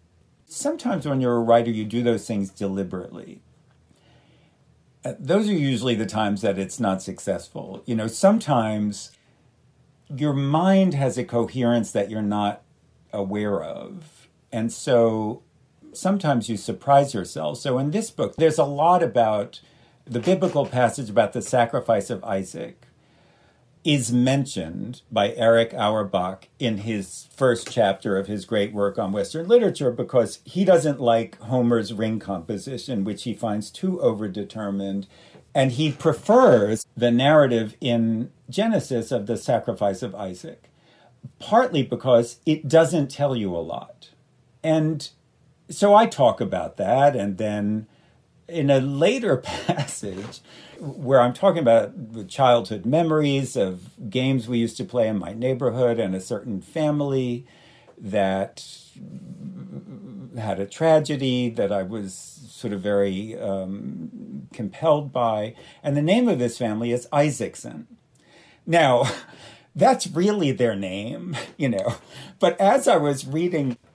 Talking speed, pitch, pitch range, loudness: 135 wpm, 120 Hz, 105-145 Hz, -22 LUFS